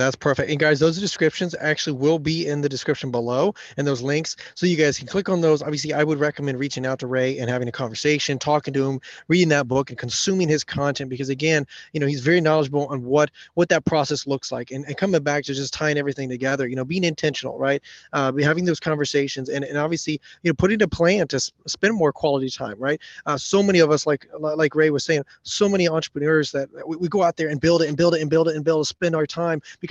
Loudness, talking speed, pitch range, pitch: -22 LUFS, 255 wpm, 140-165 Hz, 150 Hz